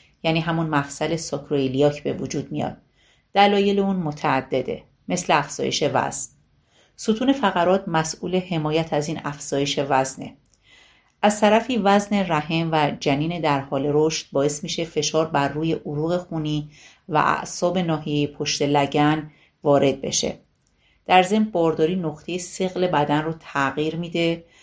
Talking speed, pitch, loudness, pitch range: 130 wpm, 160 Hz, -22 LUFS, 145-180 Hz